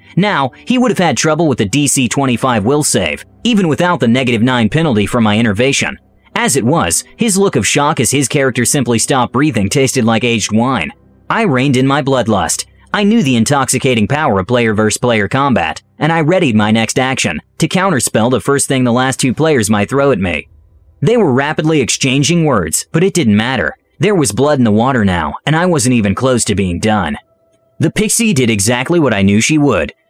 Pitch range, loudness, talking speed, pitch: 110-150 Hz, -12 LUFS, 205 wpm, 130 Hz